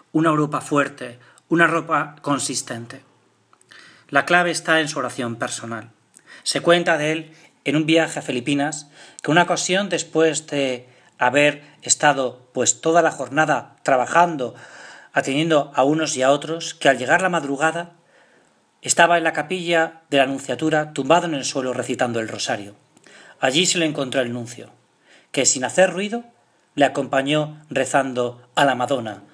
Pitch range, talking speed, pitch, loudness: 130-160 Hz, 155 wpm, 145 Hz, -20 LUFS